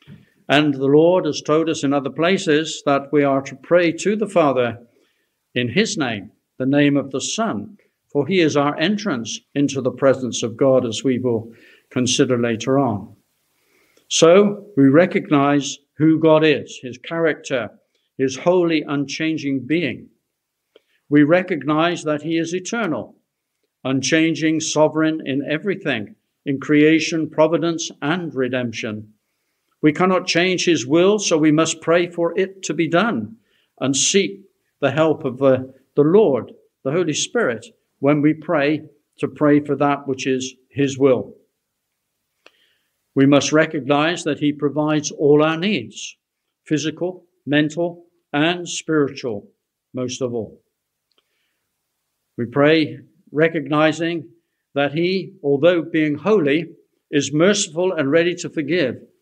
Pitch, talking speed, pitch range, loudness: 150 Hz, 135 wpm, 140-165 Hz, -19 LUFS